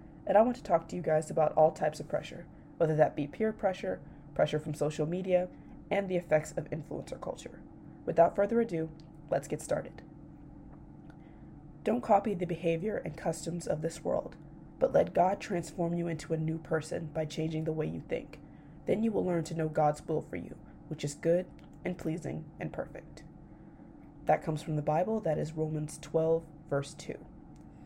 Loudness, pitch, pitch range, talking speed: -32 LUFS, 160 Hz, 155-180 Hz, 185 wpm